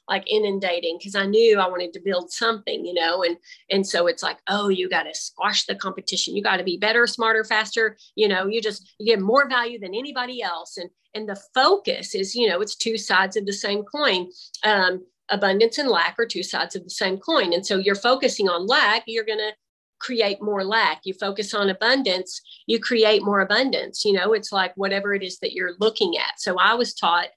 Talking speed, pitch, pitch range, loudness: 225 wpm, 200 Hz, 185-220 Hz, -22 LUFS